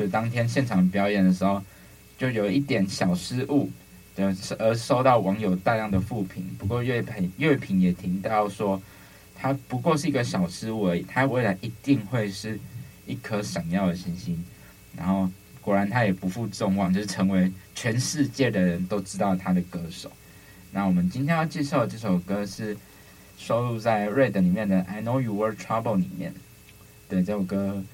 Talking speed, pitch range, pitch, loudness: 290 characters per minute, 95-125 Hz, 100 Hz, -26 LUFS